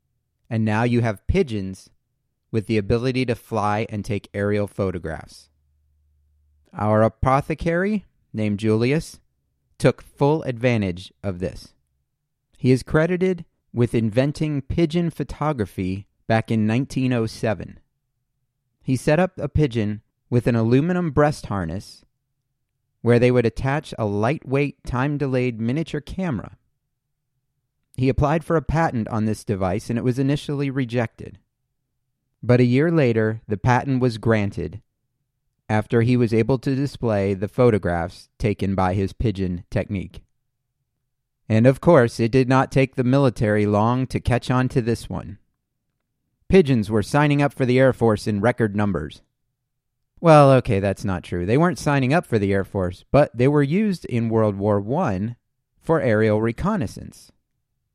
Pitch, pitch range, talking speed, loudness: 120 Hz, 105-135 Hz, 145 wpm, -21 LUFS